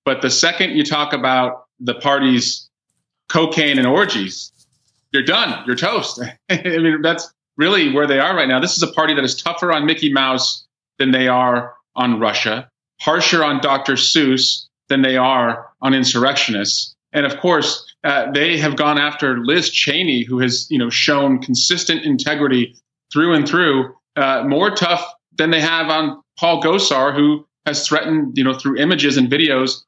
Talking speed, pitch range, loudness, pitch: 175 wpm, 130-155 Hz, -16 LUFS, 135 Hz